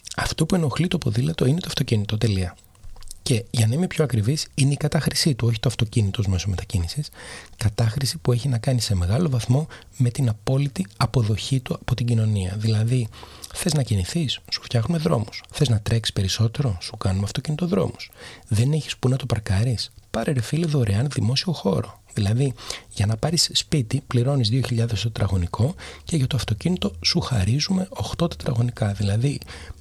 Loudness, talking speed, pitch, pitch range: -23 LUFS, 170 wpm, 120 Hz, 105-145 Hz